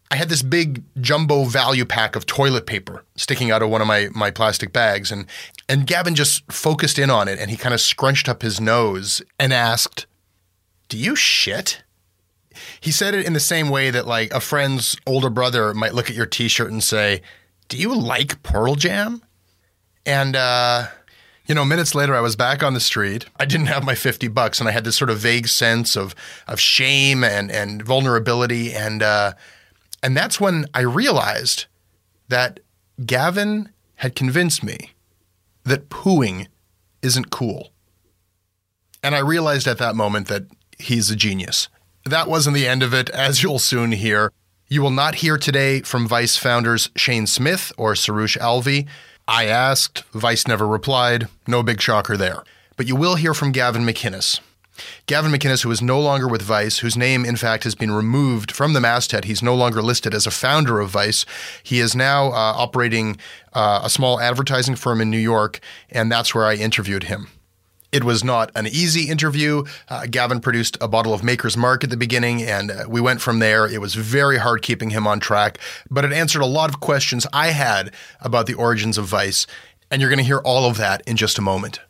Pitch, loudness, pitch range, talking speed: 120 Hz, -18 LUFS, 110-135 Hz, 195 wpm